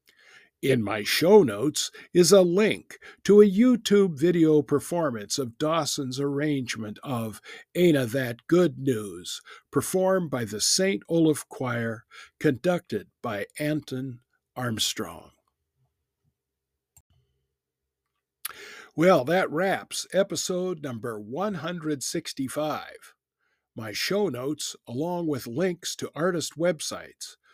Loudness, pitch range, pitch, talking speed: -25 LUFS, 120-180 Hz, 150 Hz, 100 wpm